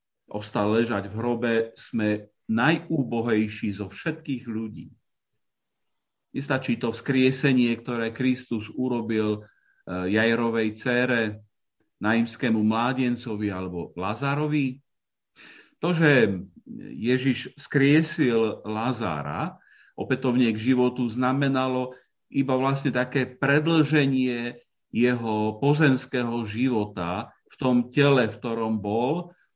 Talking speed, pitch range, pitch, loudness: 85 wpm, 110-130 Hz, 120 Hz, -25 LUFS